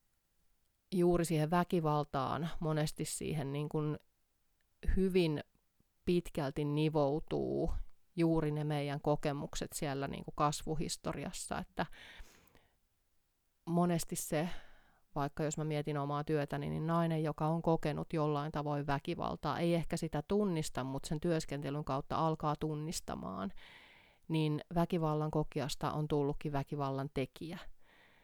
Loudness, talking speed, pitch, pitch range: -36 LUFS, 110 wpm, 150 Hz, 145-165 Hz